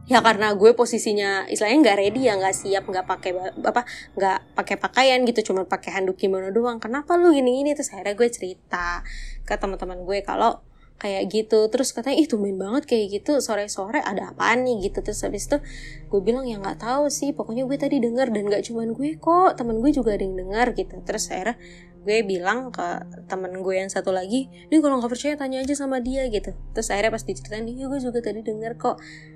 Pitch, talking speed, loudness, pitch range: 220 Hz, 215 wpm, -23 LUFS, 195-255 Hz